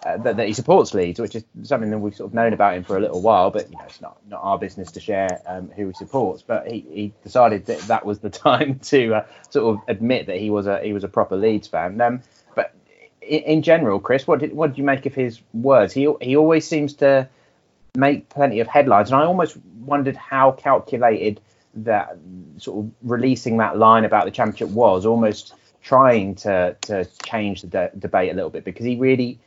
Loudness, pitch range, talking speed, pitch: -19 LUFS, 105-135 Hz, 230 wpm, 115 Hz